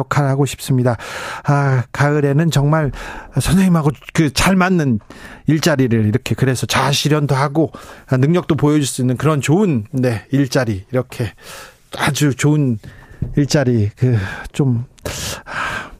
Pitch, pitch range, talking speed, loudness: 140 Hz, 125-150 Hz, 250 characters per minute, -17 LUFS